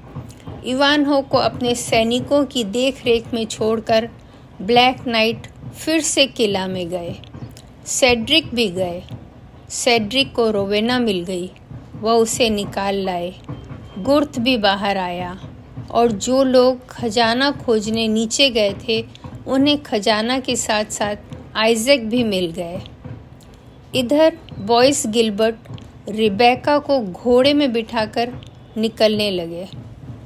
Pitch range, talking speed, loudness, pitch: 180-250 Hz, 115 wpm, -18 LUFS, 225 Hz